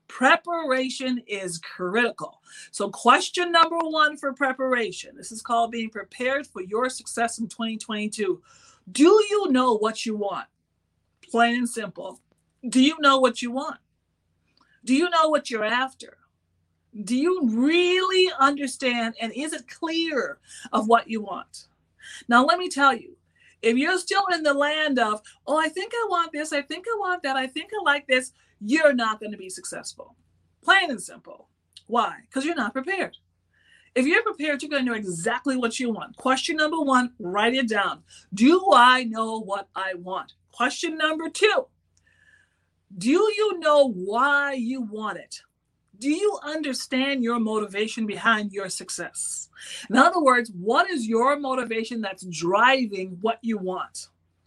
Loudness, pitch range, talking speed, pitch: -23 LUFS, 220-305 Hz, 160 wpm, 255 Hz